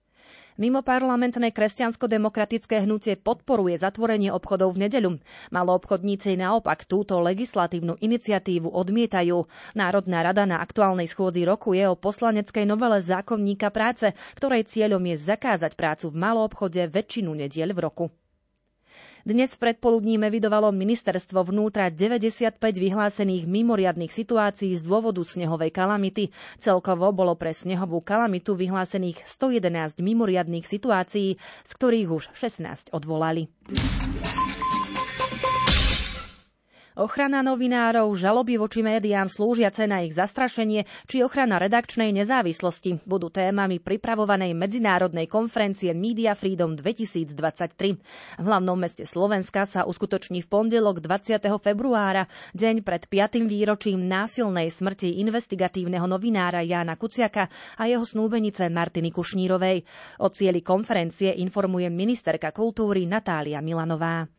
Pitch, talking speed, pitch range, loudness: 200 Hz, 115 wpm, 180-220 Hz, -24 LUFS